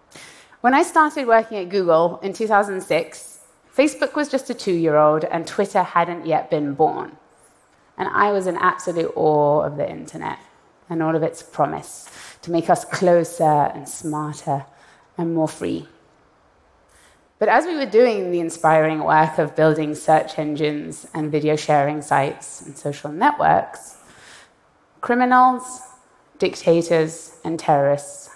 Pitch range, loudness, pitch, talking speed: 155-205 Hz, -20 LUFS, 165 Hz, 140 wpm